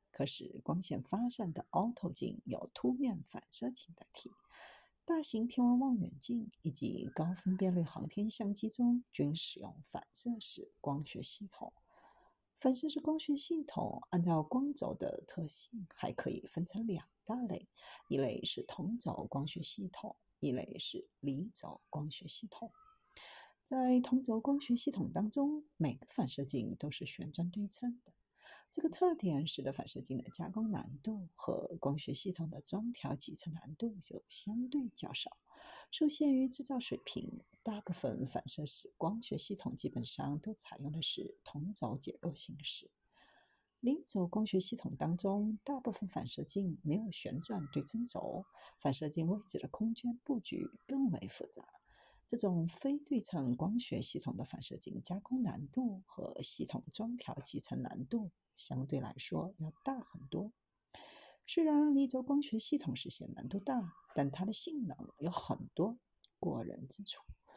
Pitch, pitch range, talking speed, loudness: 205 Hz, 165-245 Hz, 235 characters per minute, -37 LUFS